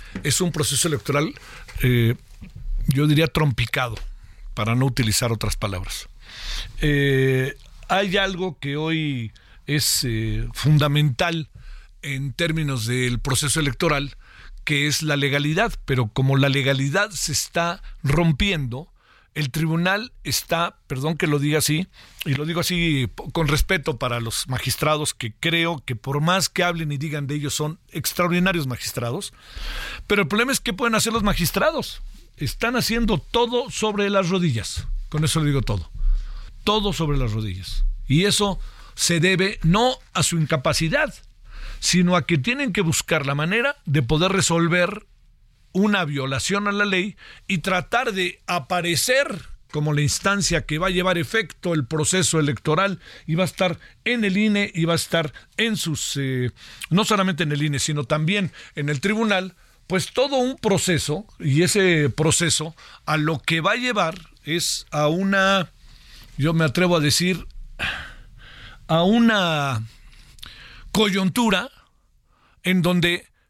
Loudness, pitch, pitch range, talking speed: -22 LUFS, 160 Hz, 140-185 Hz, 150 wpm